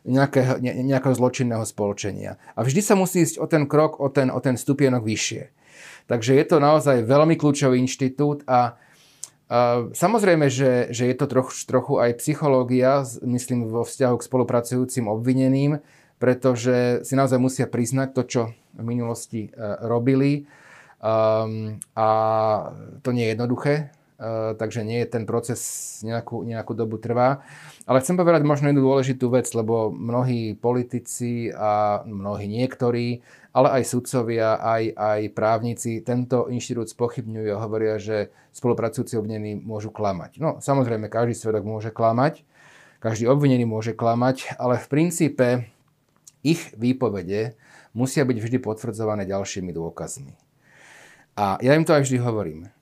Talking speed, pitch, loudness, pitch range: 140 wpm, 125 Hz, -22 LUFS, 115-135 Hz